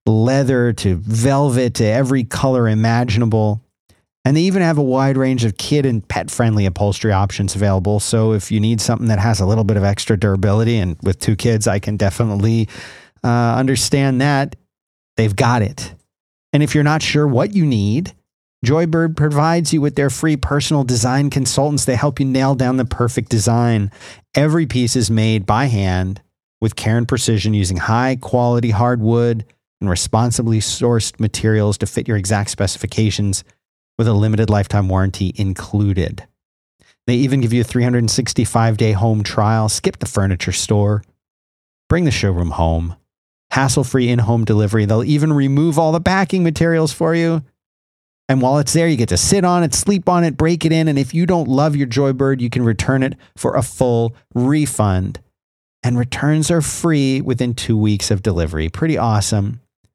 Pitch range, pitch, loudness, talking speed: 105-135 Hz, 115 Hz, -16 LUFS, 175 wpm